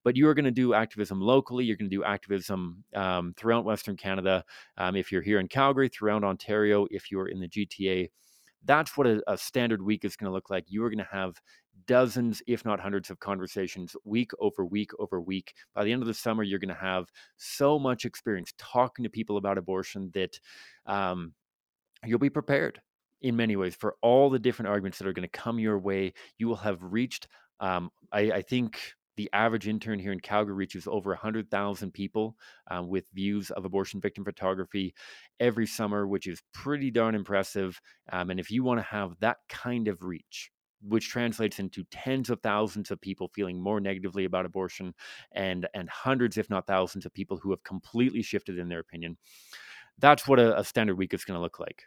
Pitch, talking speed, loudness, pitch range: 100 Hz, 205 wpm, -29 LUFS, 95-115 Hz